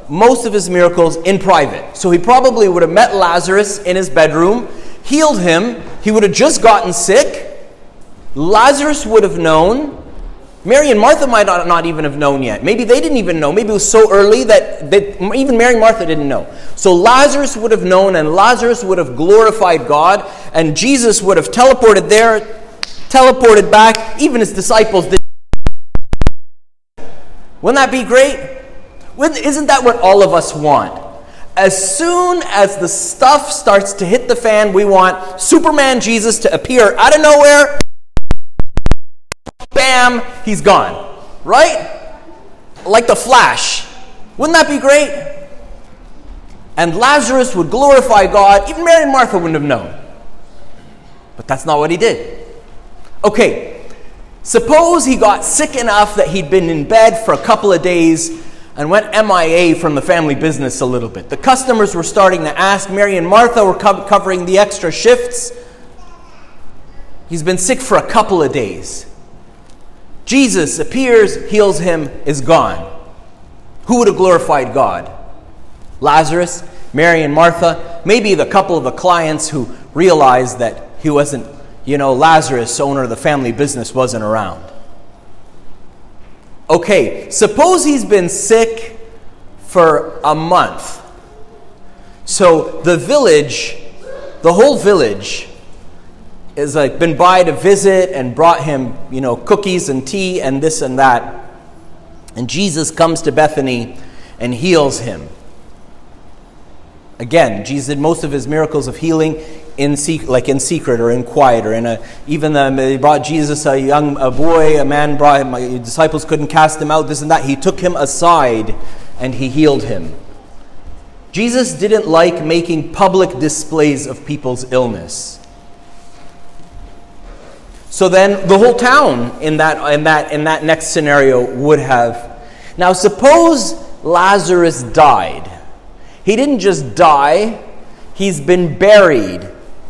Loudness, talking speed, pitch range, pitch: -11 LUFS, 150 wpm, 145-220 Hz, 180 Hz